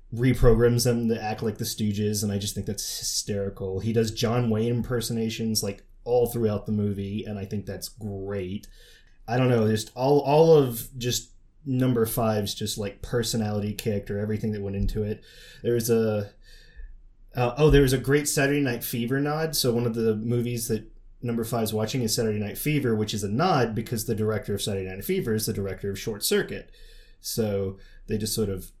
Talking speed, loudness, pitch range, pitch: 200 wpm, -26 LUFS, 105-120 Hz, 110 Hz